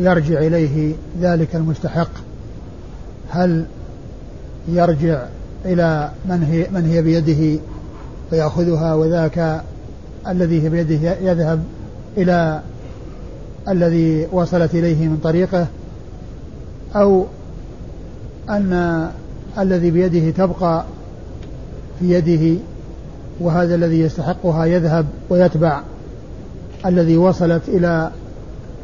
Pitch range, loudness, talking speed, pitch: 160-175 Hz, -17 LUFS, 75 wpm, 165 Hz